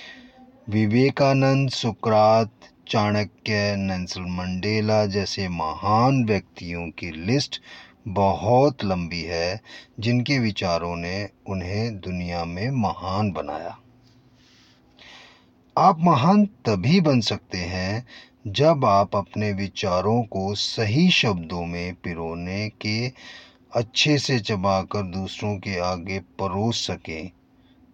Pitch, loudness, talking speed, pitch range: 105 Hz, -23 LUFS, 95 wpm, 90-125 Hz